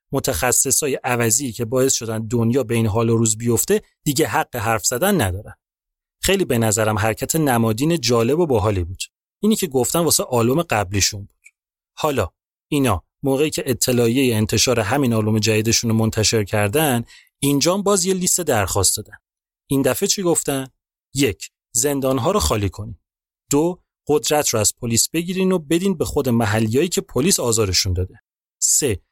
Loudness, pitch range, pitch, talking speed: -19 LUFS, 110-150 Hz, 120 Hz, 160 wpm